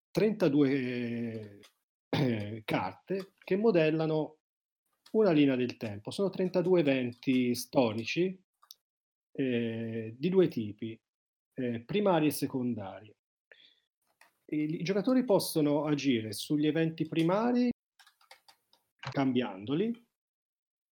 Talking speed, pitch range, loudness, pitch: 85 wpm, 120-185 Hz, -31 LUFS, 150 Hz